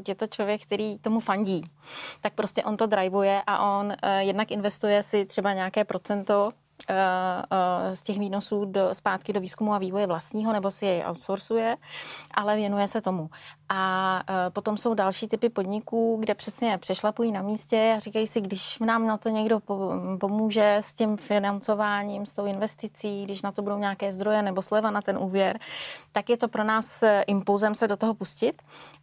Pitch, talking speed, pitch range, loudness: 205 Hz, 180 wpm, 195-215 Hz, -27 LUFS